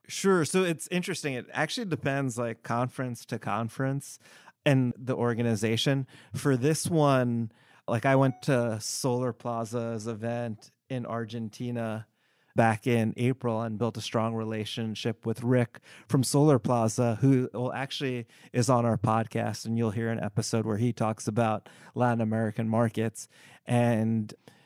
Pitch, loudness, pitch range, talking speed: 120 Hz, -29 LUFS, 115-135 Hz, 145 wpm